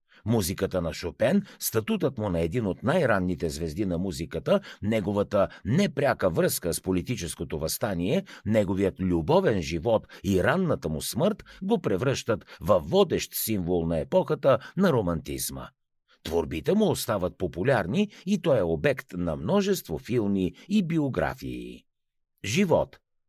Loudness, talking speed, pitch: -27 LUFS, 125 wpm, 95 Hz